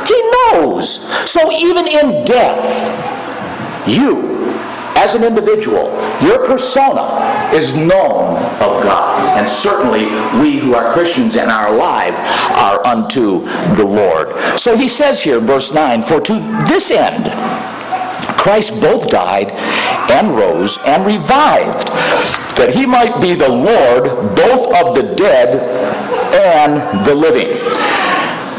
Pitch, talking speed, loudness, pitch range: 275 Hz, 120 wpm, -12 LUFS, 220-365 Hz